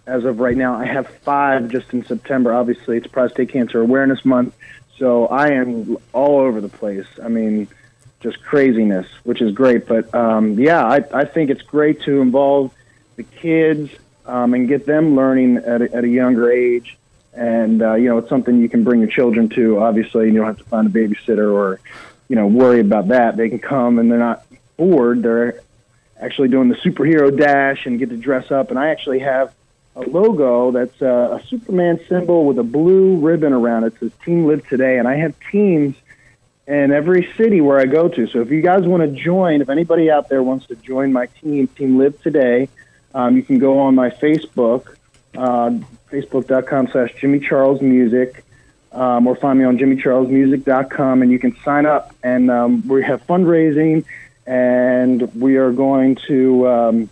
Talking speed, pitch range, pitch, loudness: 195 wpm, 120-140 Hz, 130 Hz, -15 LUFS